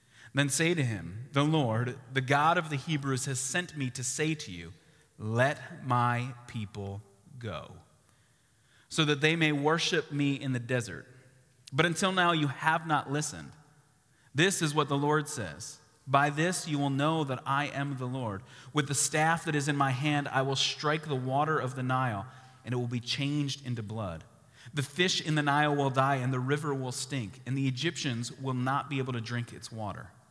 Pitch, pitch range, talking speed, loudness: 135 Hz, 125-150 Hz, 200 wpm, -30 LUFS